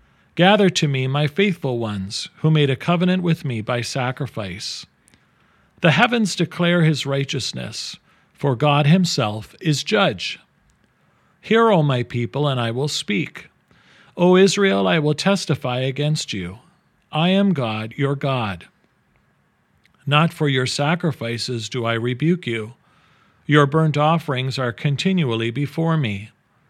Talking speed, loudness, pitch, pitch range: 135 wpm, -20 LUFS, 145 Hz, 125-170 Hz